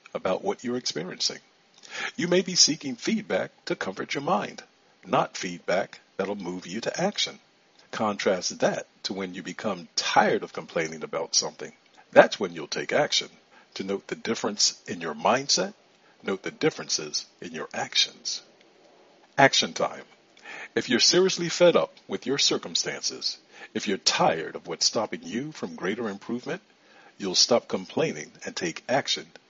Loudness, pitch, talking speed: -26 LUFS, 120 Hz, 155 wpm